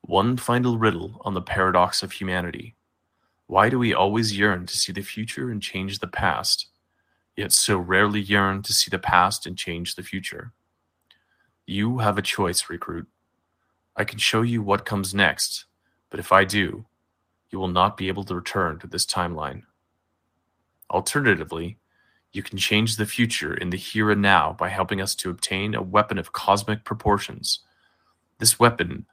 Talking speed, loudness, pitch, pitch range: 170 wpm, -22 LUFS, 100 Hz, 90-110 Hz